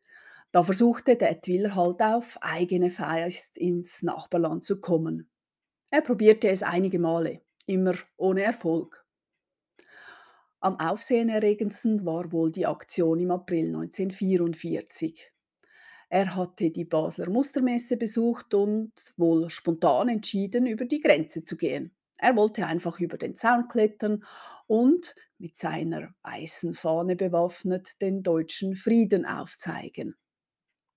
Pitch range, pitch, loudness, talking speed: 170-230 Hz, 190 Hz, -26 LUFS, 120 wpm